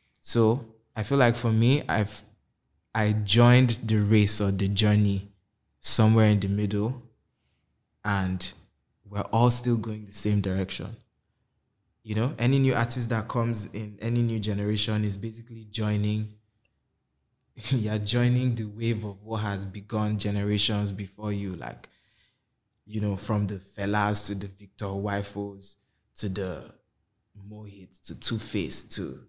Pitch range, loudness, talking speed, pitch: 100-115 Hz, -26 LUFS, 140 wpm, 105 Hz